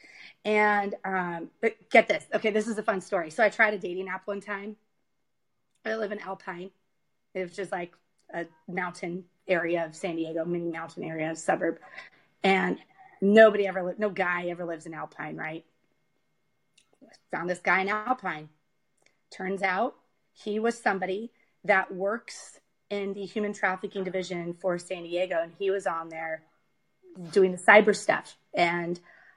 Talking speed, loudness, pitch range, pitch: 160 wpm, -28 LUFS, 175-210 Hz, 190 Hz